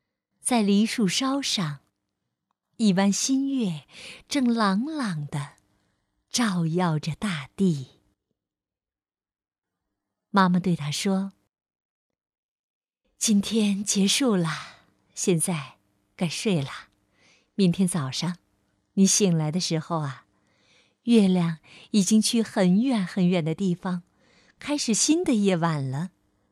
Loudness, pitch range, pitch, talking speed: -24 LUFS, 150-210 Hz, 185 Hz, 145 characters per minute